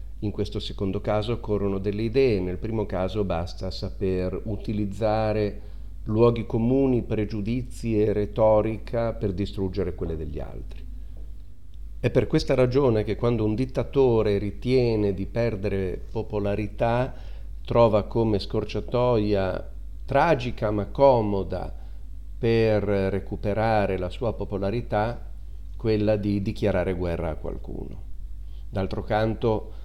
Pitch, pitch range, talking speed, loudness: 105 Hz, 95-115 Hz, 110 wpm, -25 LUFS